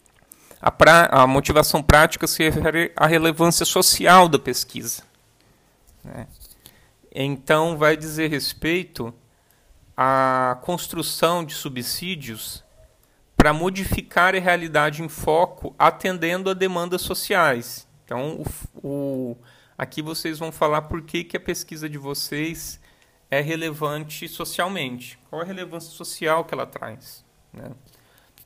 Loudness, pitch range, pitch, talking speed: -20 LUFS, 140-170 Hz, 155 Hz, 120 wpm